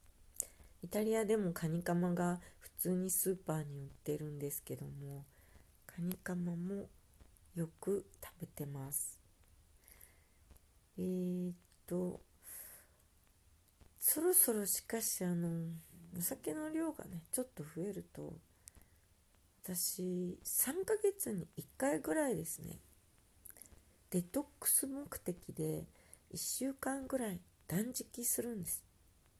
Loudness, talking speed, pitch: -38 LUFS, 200 characters per minute, 165 Hz